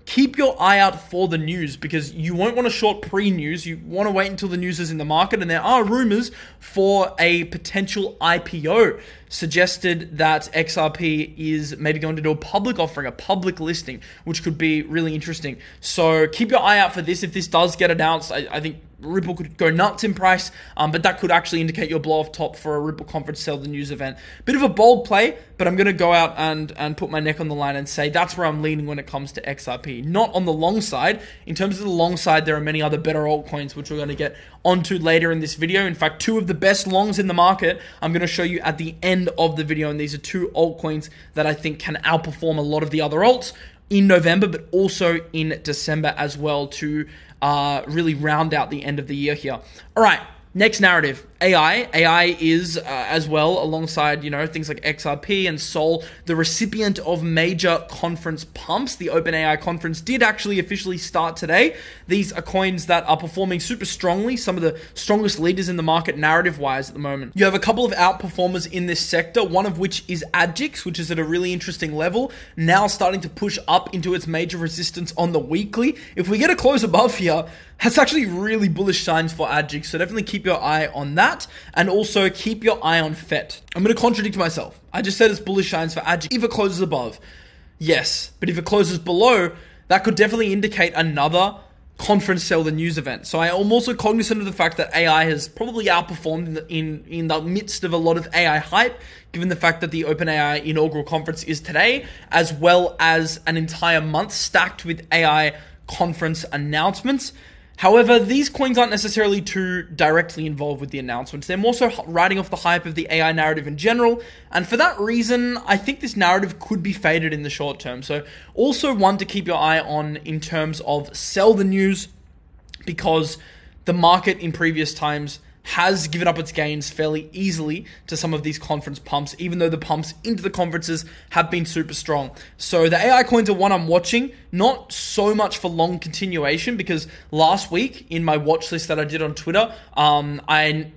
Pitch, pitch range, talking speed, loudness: 170 Hz, 155-195 Hz, 215 wpm, -20 LUFS